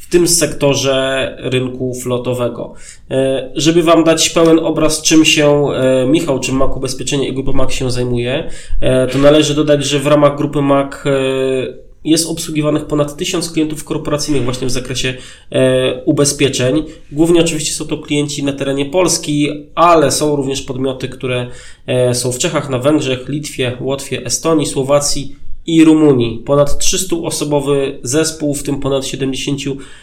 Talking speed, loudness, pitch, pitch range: 140 wpm, -14 LUFS, 140 Hz, 130-155 Hz